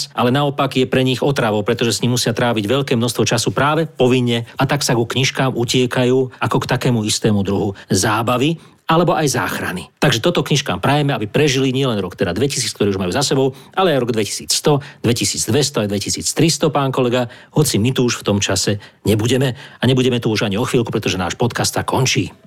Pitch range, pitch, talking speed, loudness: 110-135 Hz, 125 Hz, 200 wpm, -17 LUFS